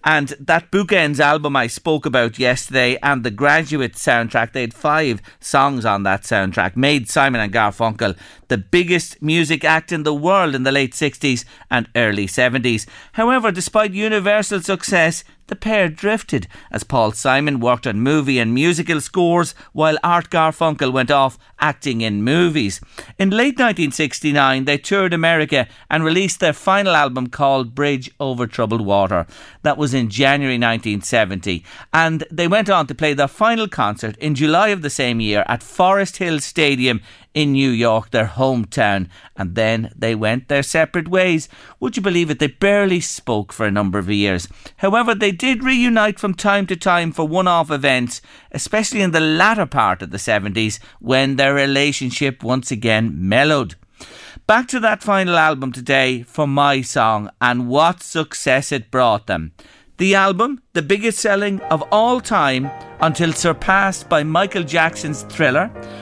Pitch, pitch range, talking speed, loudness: 145 Hz, 120-175 Hz, 165 wpm, -17 LUFS